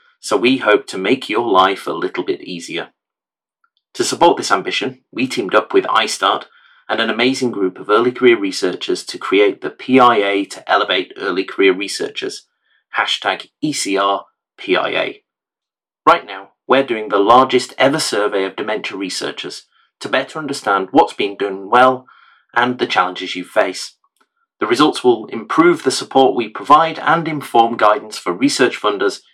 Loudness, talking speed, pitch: -16 LUFS, 155 wpm, 330 Hz